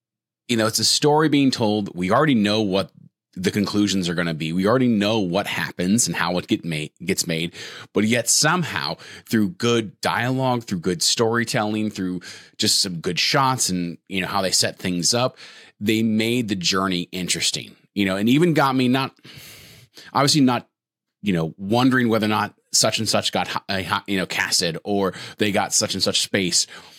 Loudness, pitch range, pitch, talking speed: -21 LUFS, 90-120 Hz, 105 Hz, 190 wpm